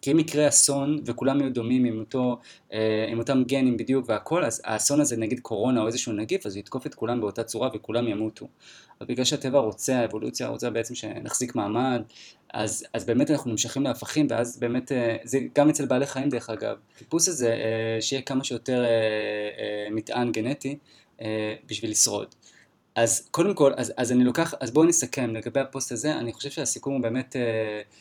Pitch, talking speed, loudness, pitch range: 120 Hz, 175 wpm, -25 LUFS, 110-135 Hz